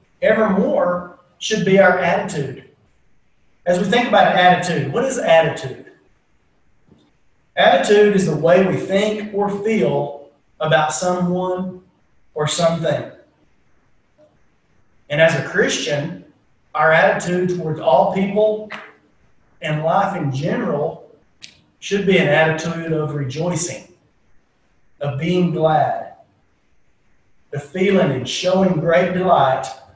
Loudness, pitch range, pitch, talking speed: -17 LUFS, 160-195 Hz, 180 Hz, 105 wpm